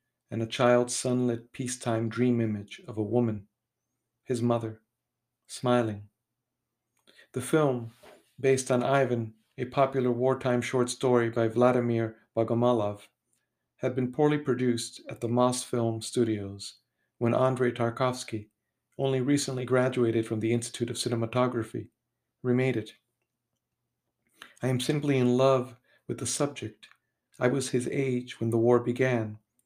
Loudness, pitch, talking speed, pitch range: -28 LUFS, 120 Hz, 130 wpm, 115-130 Hz